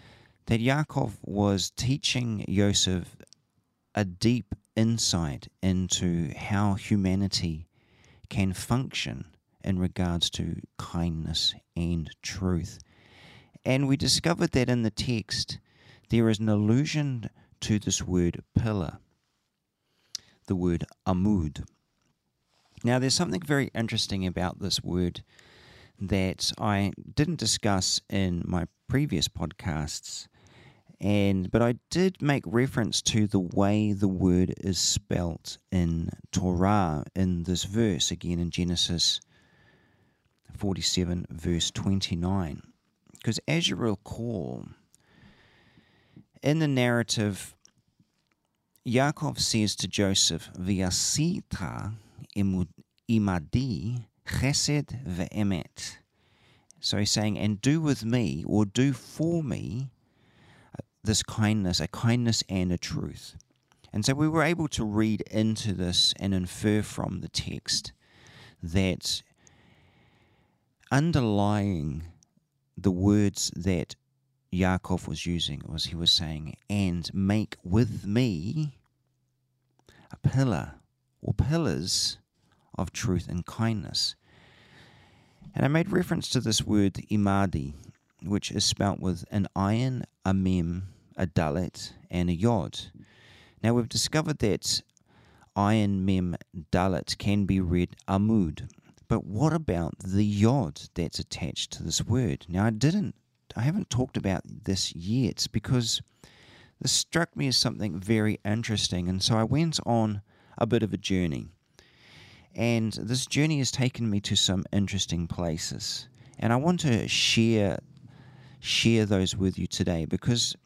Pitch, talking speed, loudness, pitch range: 105 Hz, 115 wpm, -27 LUFS, 95-125 Hz